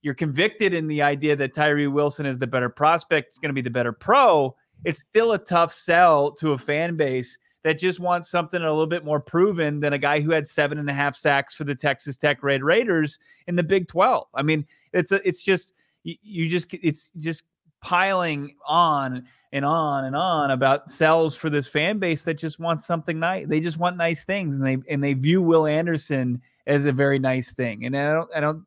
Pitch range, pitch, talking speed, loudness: 140-170 Hz, 155 Hz, 225 wpm, -22 LUFS